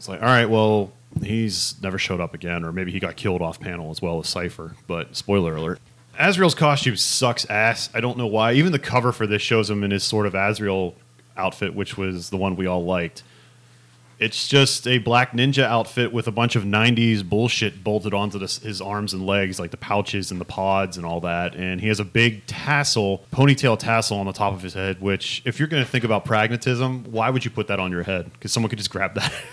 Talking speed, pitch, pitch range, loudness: 235 wpm, 105 Hz, 95-120 Hz, -22 LUFS